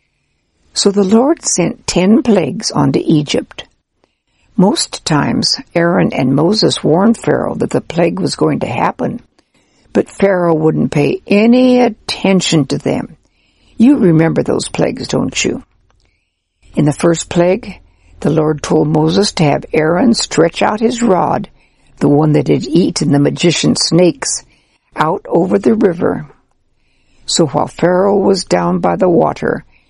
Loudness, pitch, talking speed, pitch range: -13 LUFS, 170 Hz, 140 wpm, 150-200 Hz